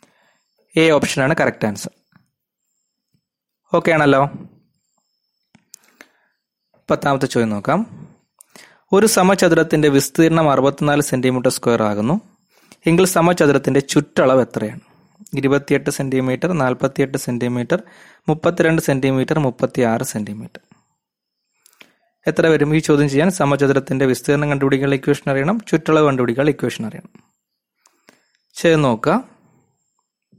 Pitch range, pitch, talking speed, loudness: 135-165 Hz, 145 Hz, 90 wpm, -17 LUFS